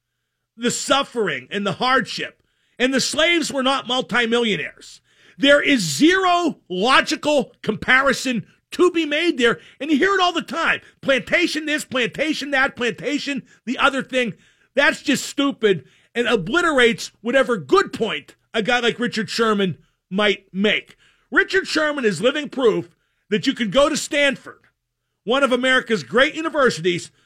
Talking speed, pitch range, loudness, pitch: 145 wpm, 215-285 Hz, -19 LUFS, 255 Hz